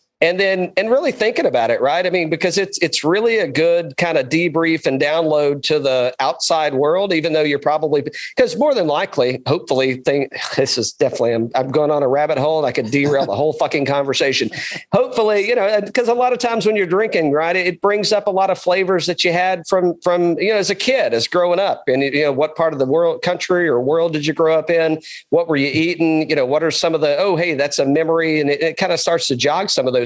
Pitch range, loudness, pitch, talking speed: 150-185 Hz, -17 LUFS, 165 Hz, 255 wpm